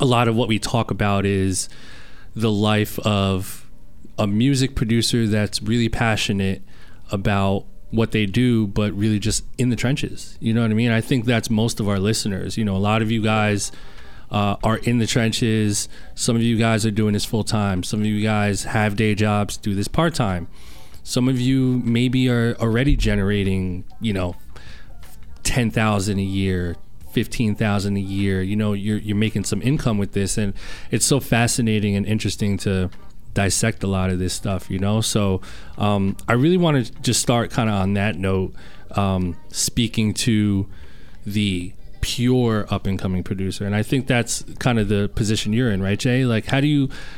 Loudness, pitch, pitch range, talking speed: -21 LUFS, 105 Hz, 100-115 Hz, 185 wpm